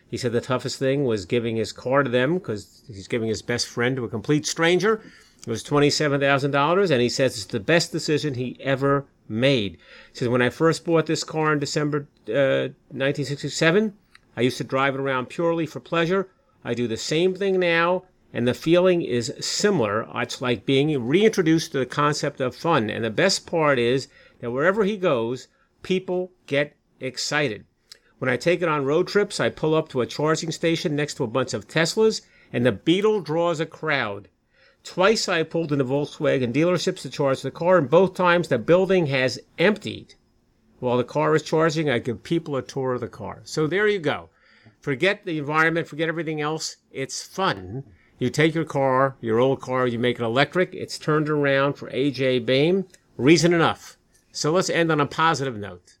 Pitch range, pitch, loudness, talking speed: 125-165 Hz, 145 Hz, -23 LUFS, 195 wpm